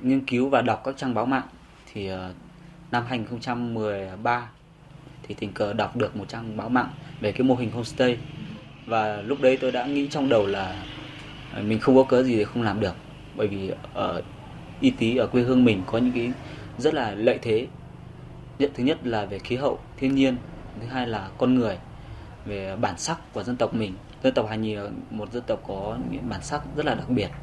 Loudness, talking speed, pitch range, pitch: -25 LUFS, 210 wpm, 105-135 Hz, 120 Hz